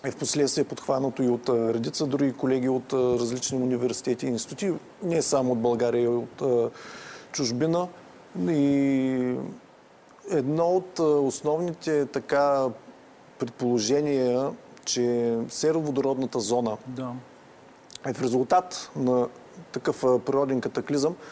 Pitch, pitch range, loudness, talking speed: 130 Hz, 125-145 Hz, -26 LUFS, 105 wpm